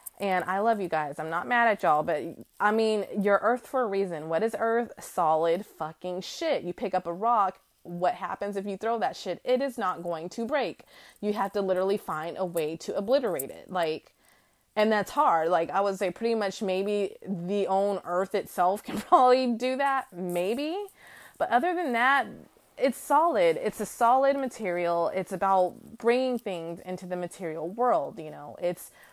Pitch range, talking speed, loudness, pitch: 180-240 Hz, 190 wpm, -28 LUFS, 200 Hz